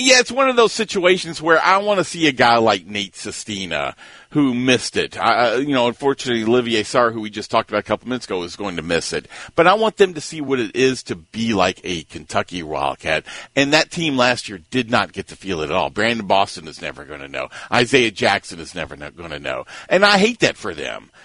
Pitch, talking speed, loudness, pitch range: 120 Hz, 245 wpm, -18 LUFS, 100-165 Hz